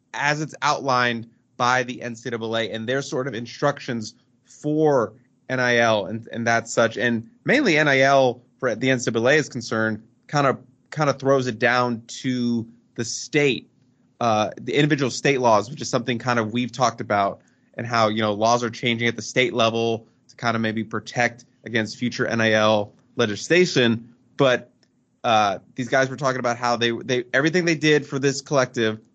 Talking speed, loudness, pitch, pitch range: 170 wpm, -22 LUFS, 125 Hz, 115-130 Hz